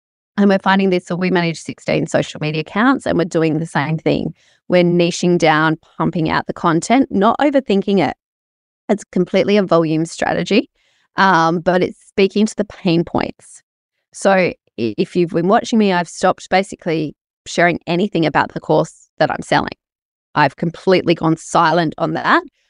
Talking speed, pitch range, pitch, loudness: 165 wpm, 165-200 Hz, 180 Hz, -16 LUFS